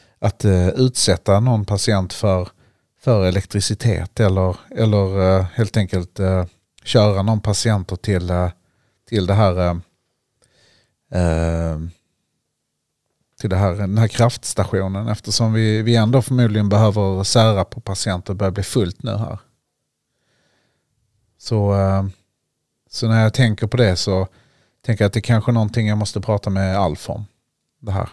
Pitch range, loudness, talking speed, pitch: 95-115 Hz, -18 LUFS, 145 wpm, 105 Hz